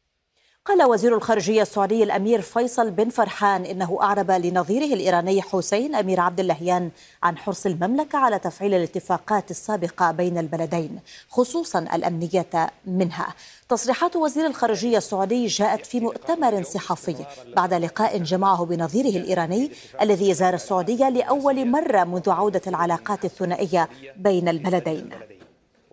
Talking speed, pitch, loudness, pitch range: 120 wpm, 195 Hz, -22 LUFS, 180-225 Hz